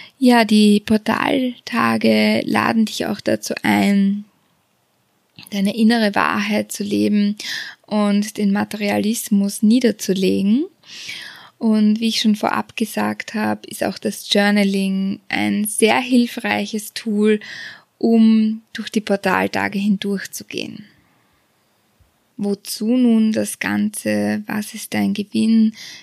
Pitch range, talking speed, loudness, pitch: 195-220 Hz, 105 wpm, -18 LUFS, 210 Hz